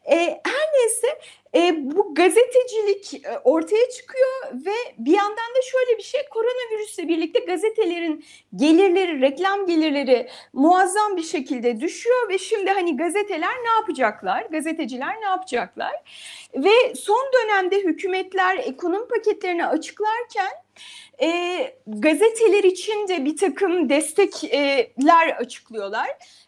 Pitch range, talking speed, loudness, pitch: 315-435 Hz, 105 wpm, -21 LUFS, 375 Hz